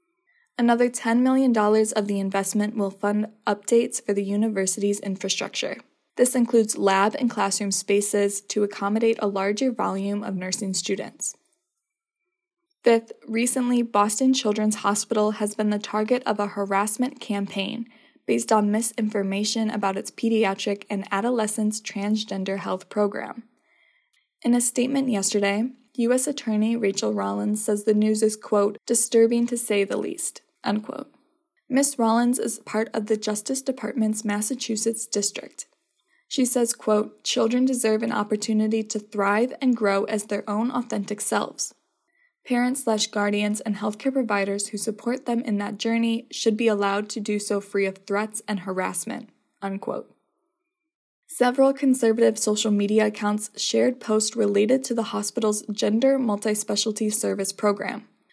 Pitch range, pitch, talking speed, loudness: 205-245 Hz, 220 Hz, 140 wpm, -24 LUFS